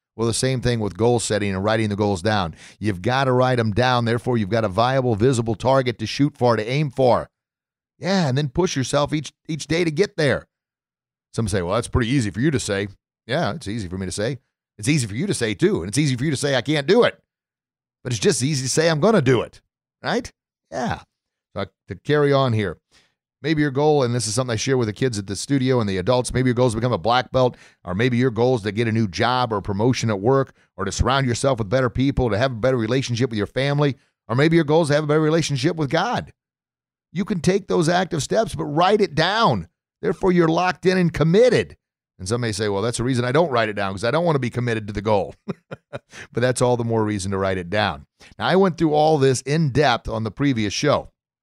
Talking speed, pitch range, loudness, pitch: 260 wpm, 110-150 Hz, -21 LUFS, 125 Hz